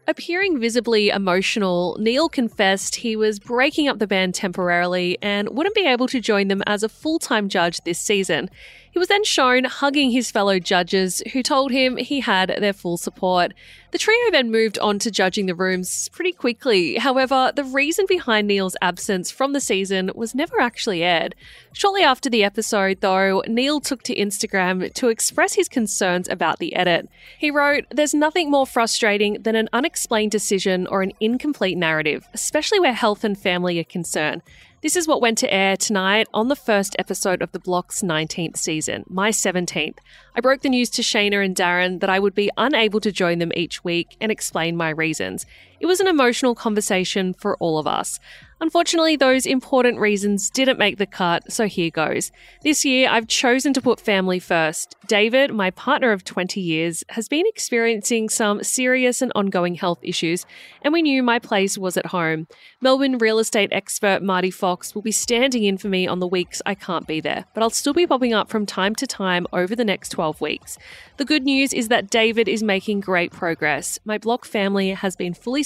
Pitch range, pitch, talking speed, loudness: 185-260 Hz, 215 Hz, 195 wpm, -20 LUFS